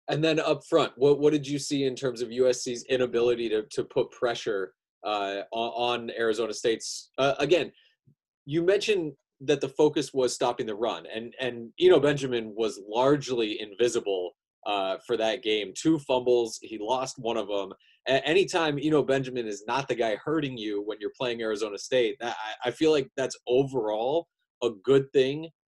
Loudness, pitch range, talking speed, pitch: -27 LUFS, 115-150 Hz, 185 wpm, 130 Hz